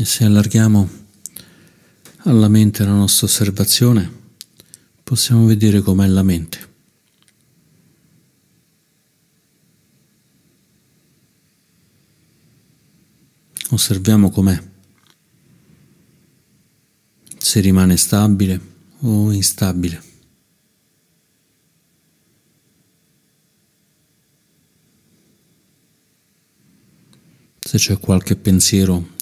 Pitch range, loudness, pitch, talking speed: 95-115 Hz, -14 LUFS, 105 Hz, 50 wpm